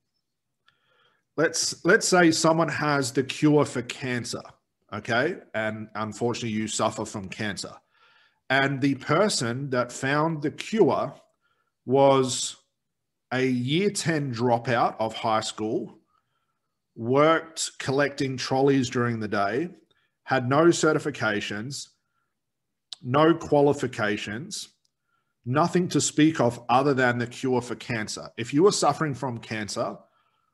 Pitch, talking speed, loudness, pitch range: 130 Hz, 115 wpm, -25 LUFS, 115-150 Hz